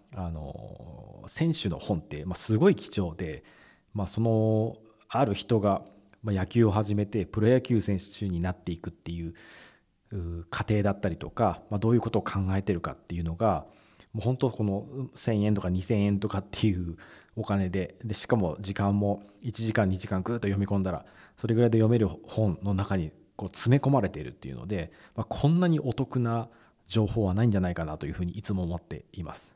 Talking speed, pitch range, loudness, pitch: 355 characters per minute, 90-115 Hz, -29 LUFS, 100 Hz